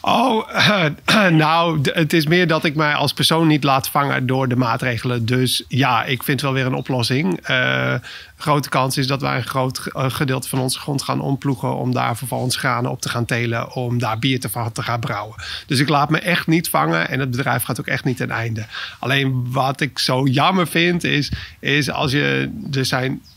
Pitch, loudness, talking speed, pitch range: 135 Hz, -19 LUFS, 215 wpm, 125-150 Hz